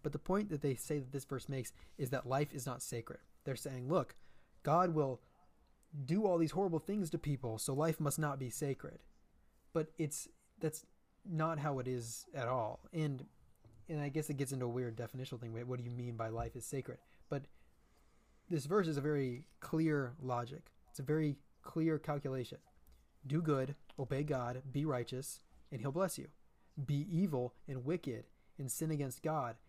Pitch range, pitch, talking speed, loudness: 125-155 Hz, 140 Hz, 190 wpm, -40 LUFS